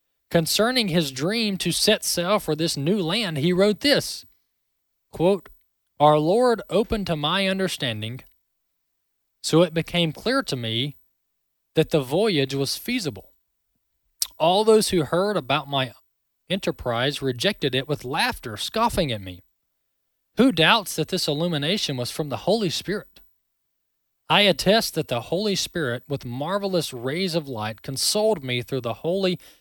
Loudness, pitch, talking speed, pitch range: -23 LUFS, 165 Hz, 145 wpm, 135-195 Hz